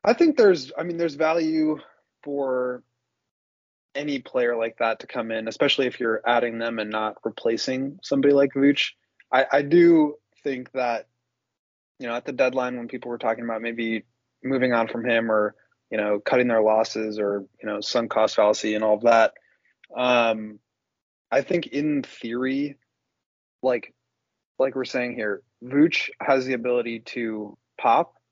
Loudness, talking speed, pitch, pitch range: -23 LUFS, 165 wpm, 125 Hz, 110-135 Hz